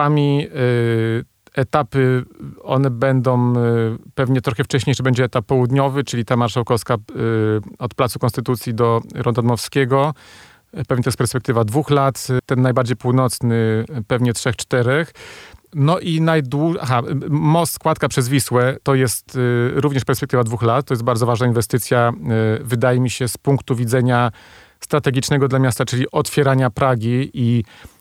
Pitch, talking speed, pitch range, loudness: 130 Hz, 130 wpm, 120-135 Hz, -18 LUFS